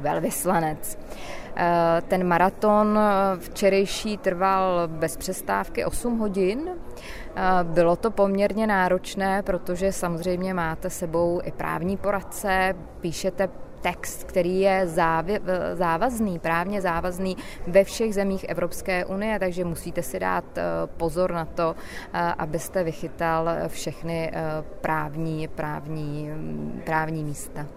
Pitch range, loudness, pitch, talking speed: 165-195 Hz, -25 LUFS, 180 Hz, 100 wpm